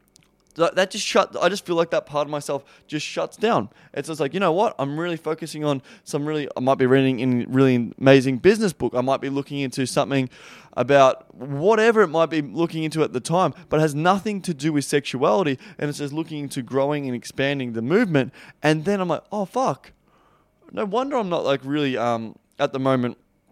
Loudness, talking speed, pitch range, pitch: -22 LUFS, 215 wpm, 135-170 Hz, 150 Hz